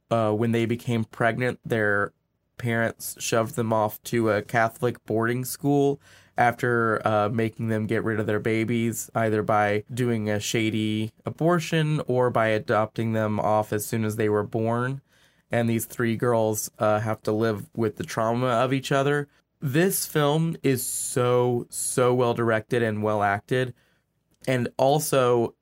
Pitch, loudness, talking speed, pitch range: 115 Hz, -25 LUFS, 155 wpm, 110-125 Hz